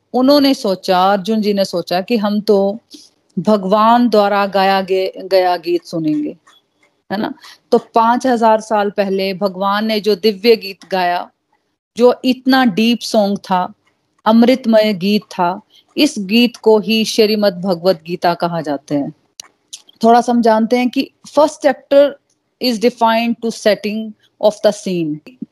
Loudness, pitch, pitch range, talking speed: -15 LUFS, 215 Hz, 195-235 Hz, 140 wpm